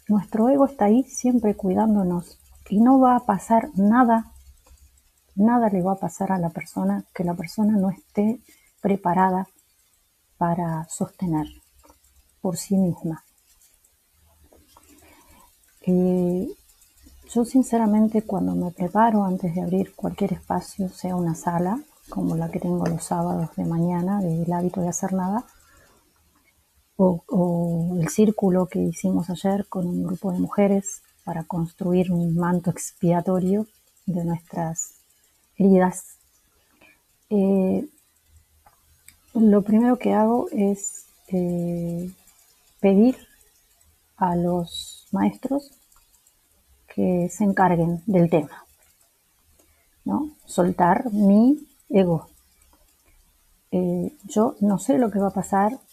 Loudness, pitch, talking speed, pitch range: -22 LUFS, 185 Hz, 115 wpm, 170-210 Hz